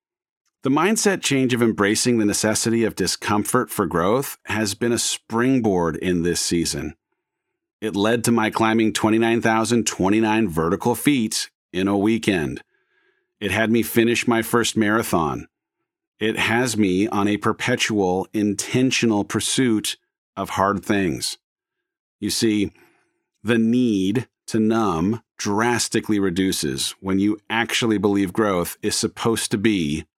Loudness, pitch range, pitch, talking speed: -21 LUFS, 100-115 Hz, 110 Hz, 125 wpm